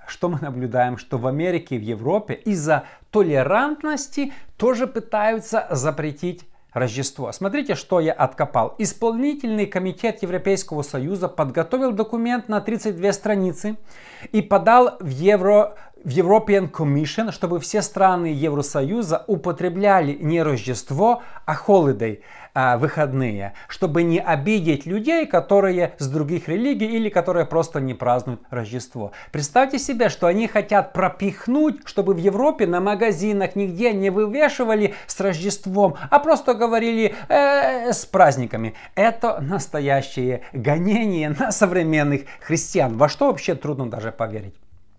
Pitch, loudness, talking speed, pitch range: 185 Hz, -21 LUFS, 125 wpm, 150-215 Hz